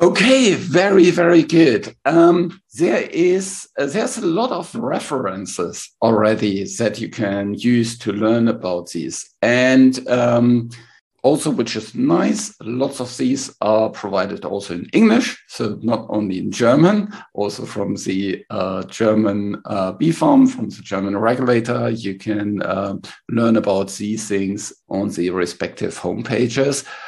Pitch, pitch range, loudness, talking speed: 115 Hz, 100-140 Hz, -18 LUFS, 140 wpm